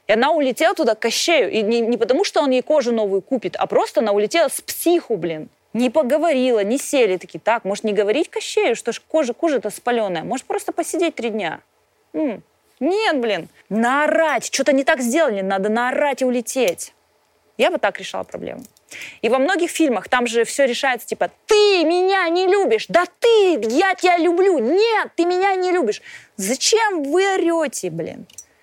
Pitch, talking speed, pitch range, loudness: 300 Hz, 180 wpm, 235-350 Hz, -19 LUFS